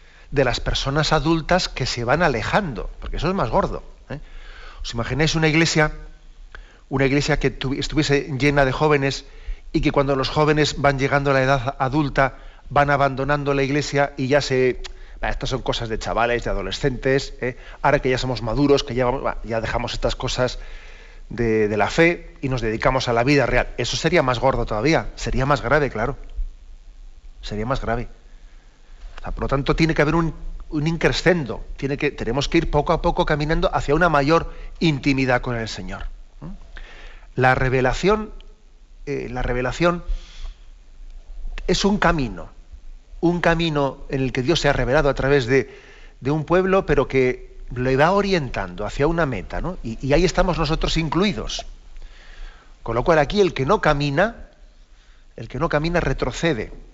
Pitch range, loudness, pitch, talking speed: 120-155 Hz, -21 LUFS, 140 Hz, 175 wpm